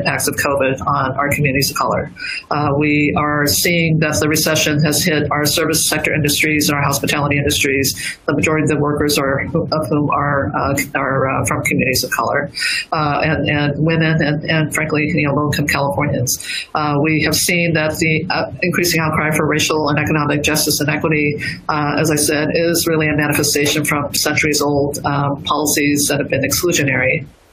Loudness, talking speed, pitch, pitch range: -15 LUFS, 185 wpm, 150 Hz, 145-155 Hz